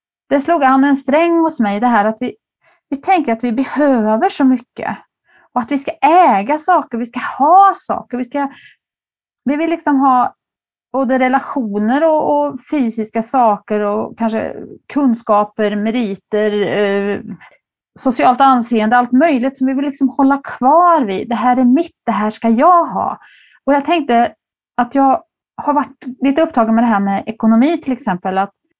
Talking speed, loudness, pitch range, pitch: 170 wpm, -14 LUFS, 230-290 Hz, 260 Hz